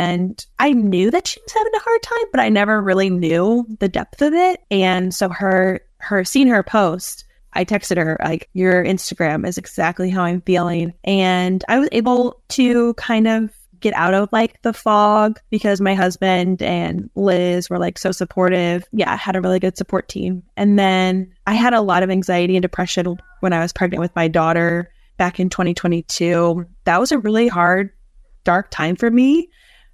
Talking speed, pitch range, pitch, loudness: 190 wpm, 180-220 Hz, 190 Hz, -17 LUFS